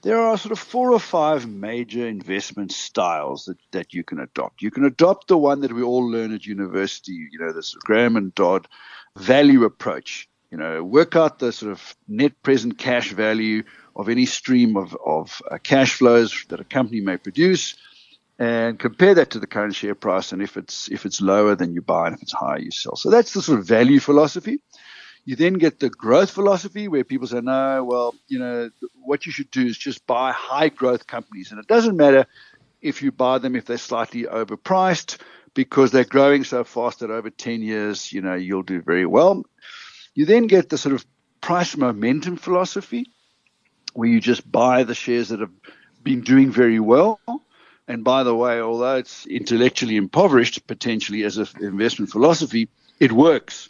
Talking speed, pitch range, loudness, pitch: 195 wpm, 115-170 Hz, -20 LUFS, 125 Hz